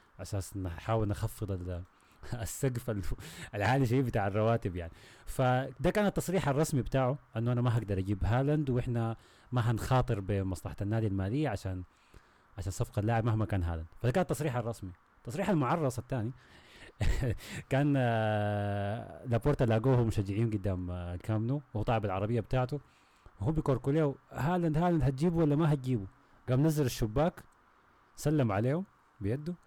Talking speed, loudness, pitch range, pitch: 130 wpm, -32 LUFS, 100-140 Hz, 115 Hz